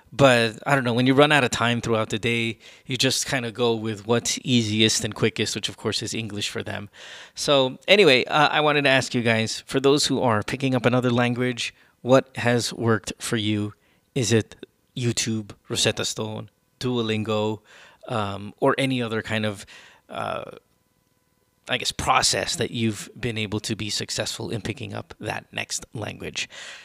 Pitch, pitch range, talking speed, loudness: 115 Hz, 110-125 Hz, 180 wpm, -23 LUFS